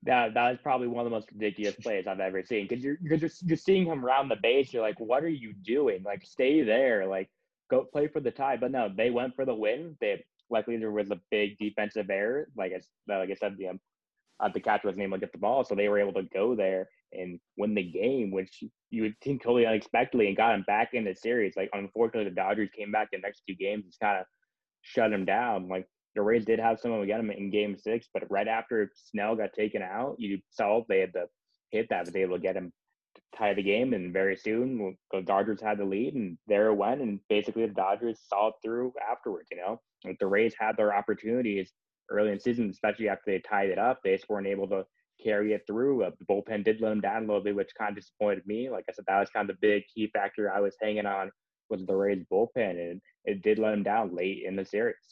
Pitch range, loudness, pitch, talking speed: 100-120 Hz, -30 LUFS, 105 Hz, 255 wpm